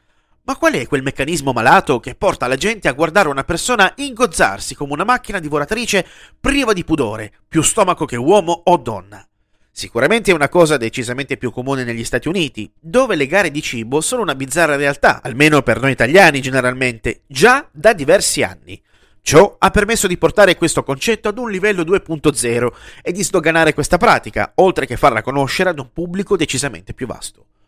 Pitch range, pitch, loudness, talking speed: 135-190 Hz, 155 Hz, -15 LUFS, 180 wpm